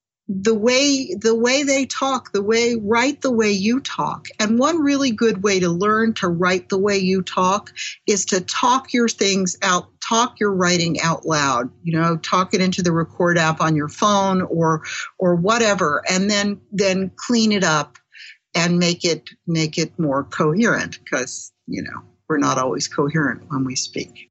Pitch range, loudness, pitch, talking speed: 170-230 Hz, -19 LUFS, 195 Hz, 185 wpm